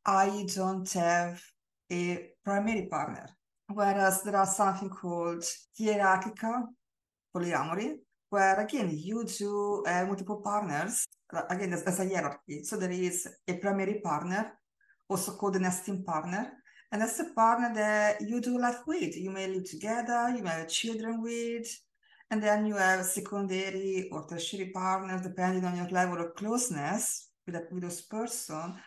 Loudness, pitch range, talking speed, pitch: -31 LUFS, 180-220 Hz, 150 wpm, 195 Hz